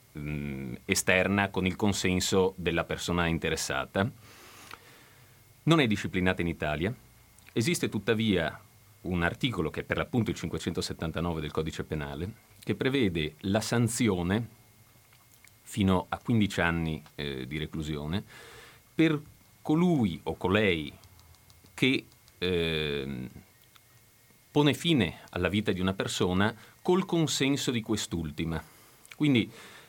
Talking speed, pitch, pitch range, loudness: 110 wpm, 95 Hz, 85-115 Hz, -29 LUFS